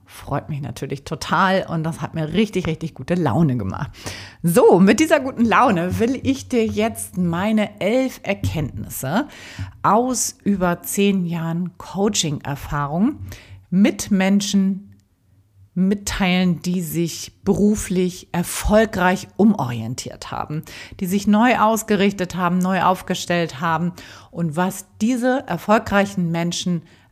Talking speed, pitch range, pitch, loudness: 115 wpm, 160-205 Hz, 180 Hz, -20 LUFS